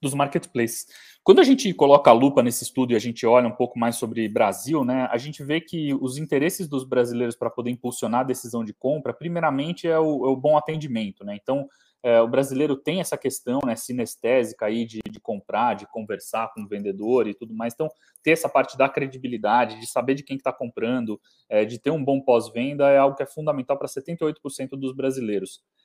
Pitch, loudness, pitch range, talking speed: 130 Hz, -23 LUFS, 120-145 Hz, 215 wpm